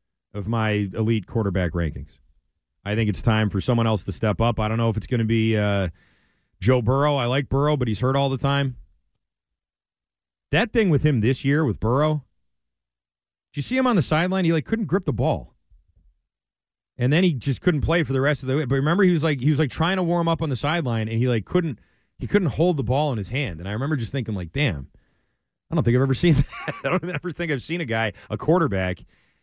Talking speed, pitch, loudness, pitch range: 245 wpm, 130 Hz, -23 LUFS, 105-155 Hz